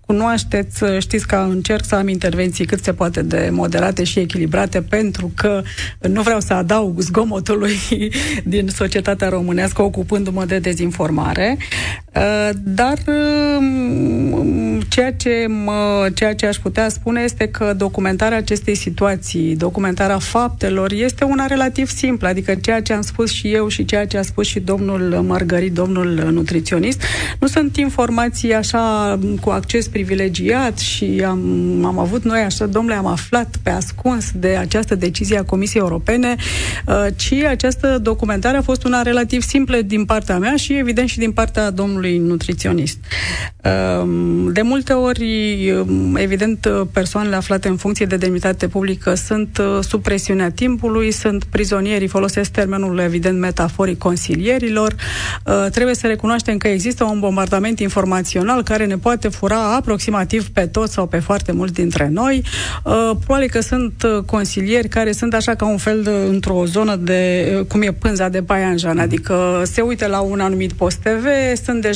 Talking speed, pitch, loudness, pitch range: 150 wpm, 200 Hz, -17 LUFS, 185-225 Hz